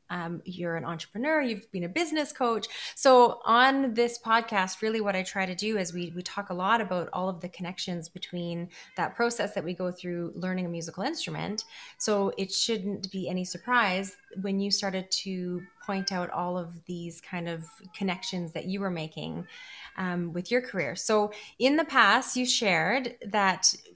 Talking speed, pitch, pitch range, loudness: 185 wpm, 190 Hz, 180-220 Hz, -28 LUFS